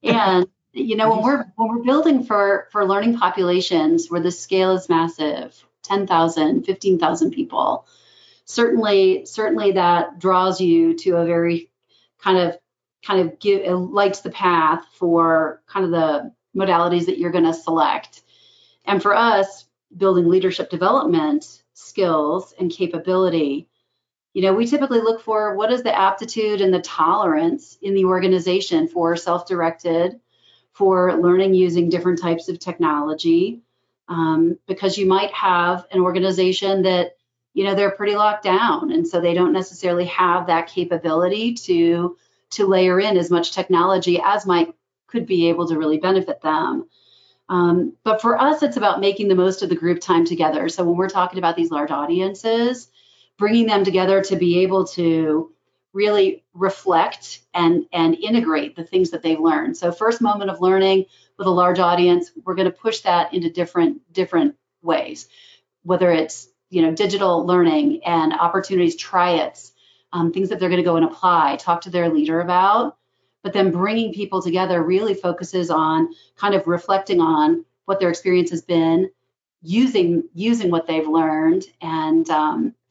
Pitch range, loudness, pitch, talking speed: 170-200 Hz, -19 LUFS, 185 Hz, 160 wpm